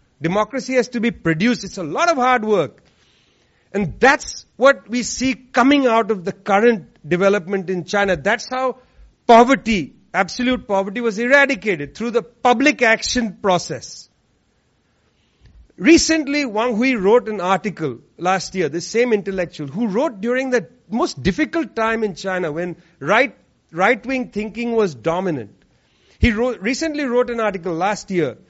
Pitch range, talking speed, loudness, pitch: 190-250 Hz, 150 wpm, -18 LUFS, 220 Hz